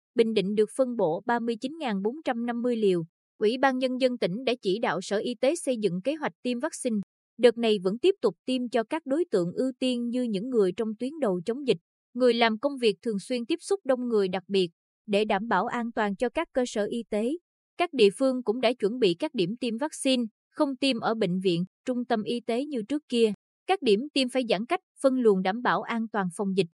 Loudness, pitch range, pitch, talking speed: -27 LUFS, 205-260 Hz, 235 Hz, 235 wpm